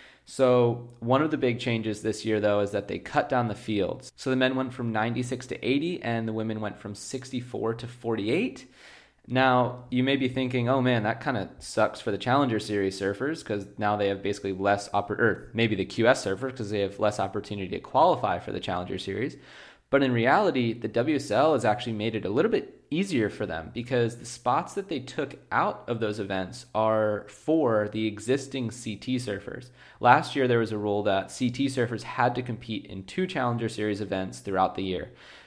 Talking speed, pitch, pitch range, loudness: 205 wpm, 115 Hz, 105-125 Hz, -27 LUFS